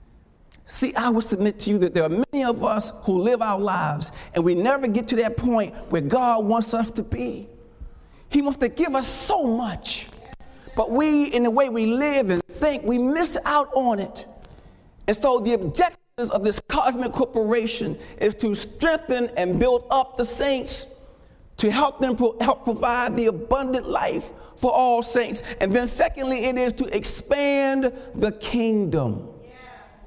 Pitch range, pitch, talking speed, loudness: 215-265 Hz, 240 Hz, 175 wpm, -23 LUFS